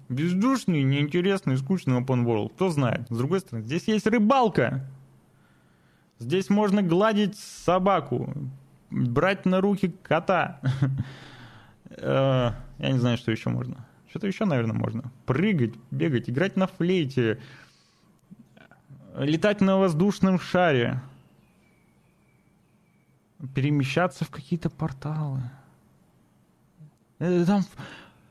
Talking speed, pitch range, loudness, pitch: 95 wpm, 130-190 Hz, -25 LUFS, 150 Hz